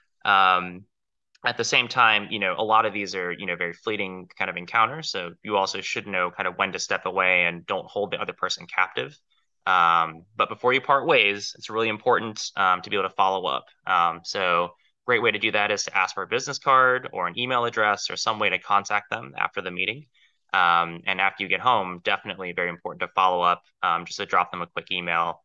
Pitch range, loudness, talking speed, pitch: 90-110 Hz, -23 LUFS, 235 wpm, 95 Hz